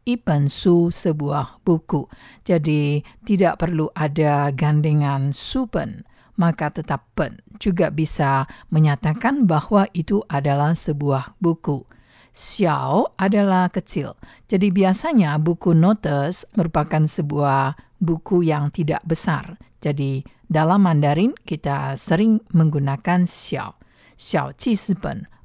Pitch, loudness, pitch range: 160 Hz, -20 LUFS, 145-185 Hz